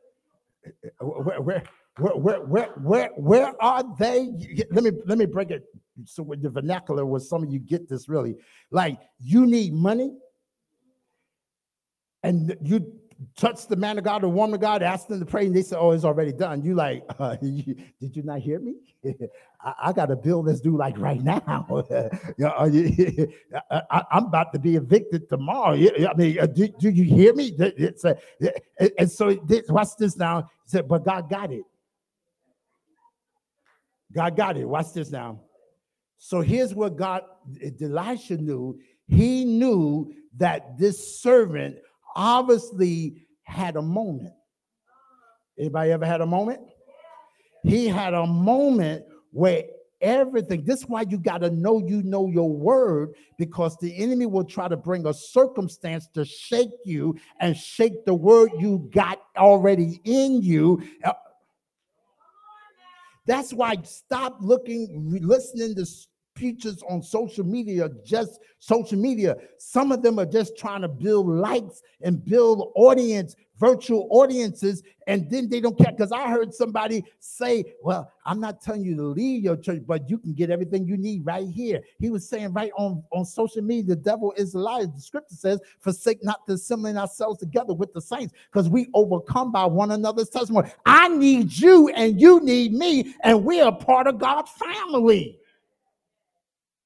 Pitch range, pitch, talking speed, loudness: 170-235 Hz, 200 Hz, 165 wpm, -22 LUFS